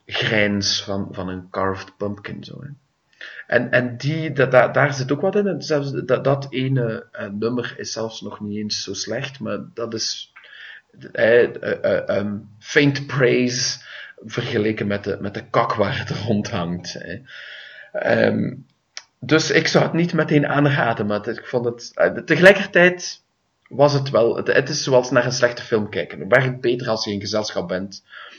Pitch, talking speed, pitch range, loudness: 120 Hz, 180 wpm, 105-145 Hz, -20 LUFS